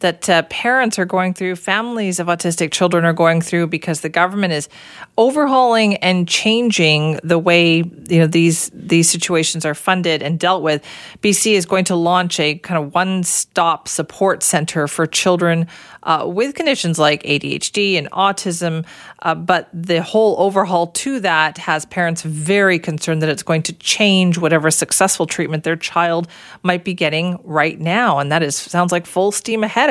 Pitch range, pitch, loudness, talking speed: 165-190 Hz, 175 Hz, -16 LUFS, 175 wpm